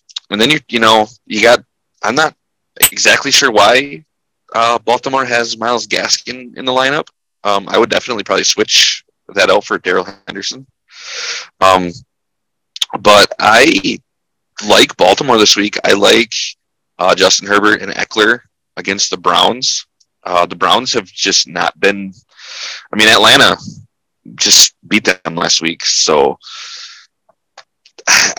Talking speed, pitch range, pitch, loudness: 135 wpm, 95-125 Hz, 110 Hz, -11 LUFS